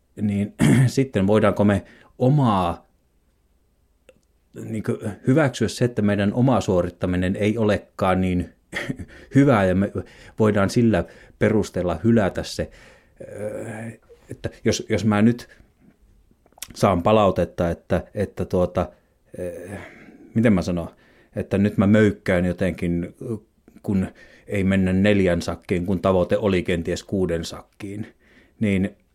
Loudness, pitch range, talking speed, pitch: -22 LUFS, 90-110 Hz, 110 wpm, 100 Hz